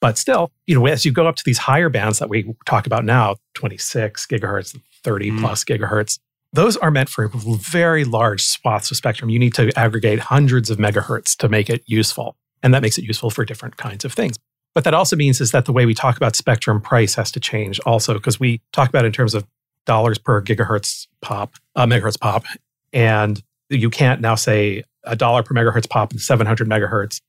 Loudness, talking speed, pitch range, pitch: -17 LUFS, 215 wpm, 110-130 Hz, 120 Hz